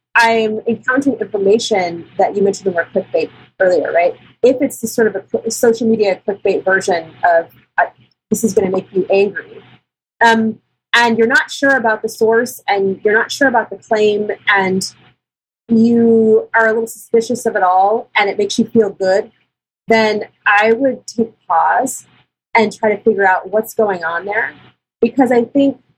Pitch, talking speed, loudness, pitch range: 220 Hz, 180 wpm, -15 LUFS, 195-230 Hz